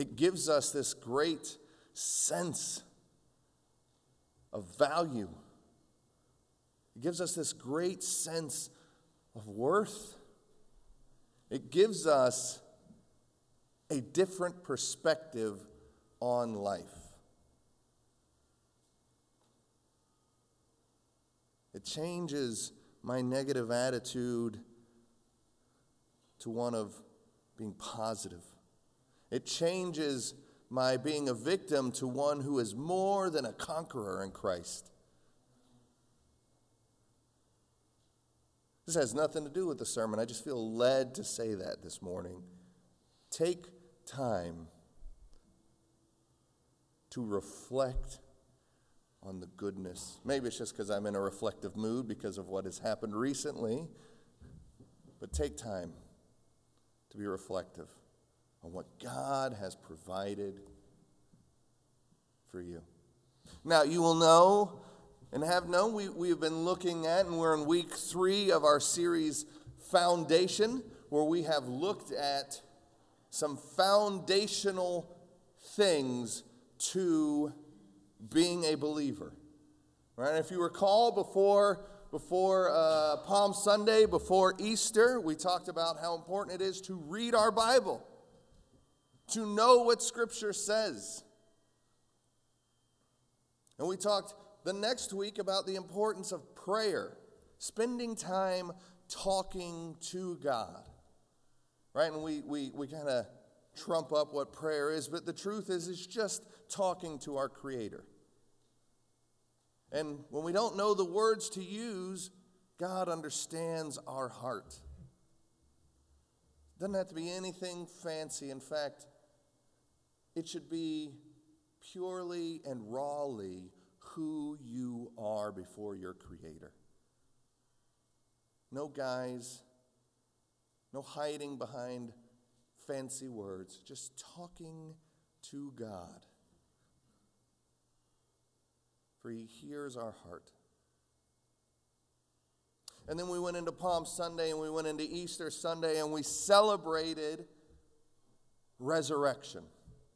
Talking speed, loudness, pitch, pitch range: 105 wpm, -34 LUFS, 150 Hz, 115-175 Hz